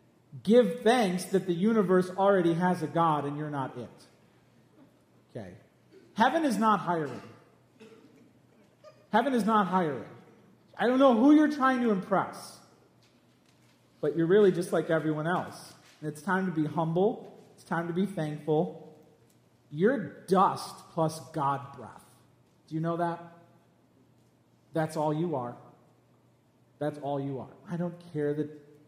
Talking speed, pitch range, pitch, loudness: 140 wpm, 150-195 Hz, 170 Hz, -28 LUFS